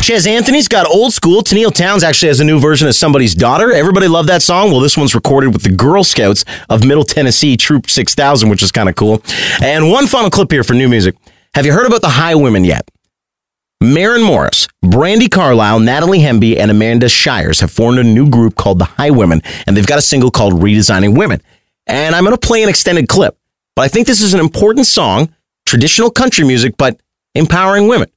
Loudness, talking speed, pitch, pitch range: -9 LUFS, 215 wpm, 145 Hz, 115-185 Hz